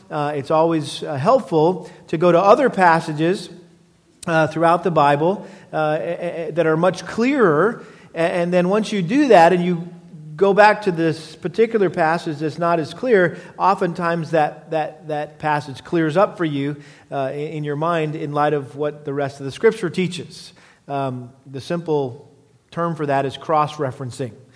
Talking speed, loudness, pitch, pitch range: 180 wpm, -19 LUFS, 160 Hz, 150-175 Hz